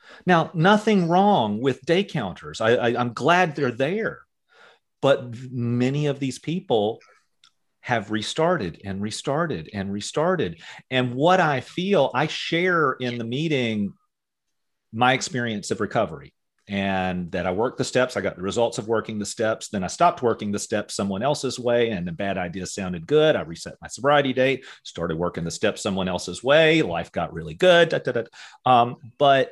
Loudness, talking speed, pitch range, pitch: -23 LUFS, 175 wpm, 100-155 Hz, 125 Hz